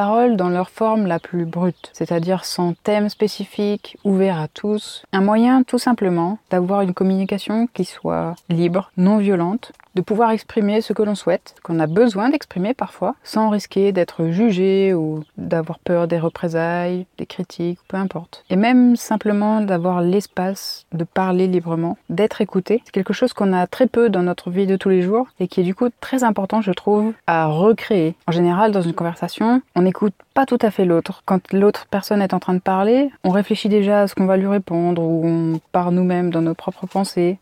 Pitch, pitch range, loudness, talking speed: 190 Hz, 175-215 Hz, -19 LUFS, 195 wpm